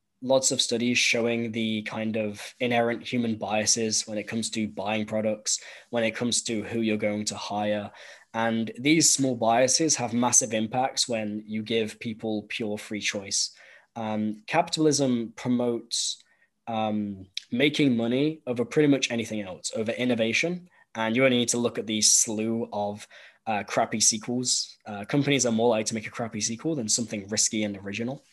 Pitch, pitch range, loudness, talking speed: 115 Hz, 110-125 Hz, -26 LUFS, 170 wpm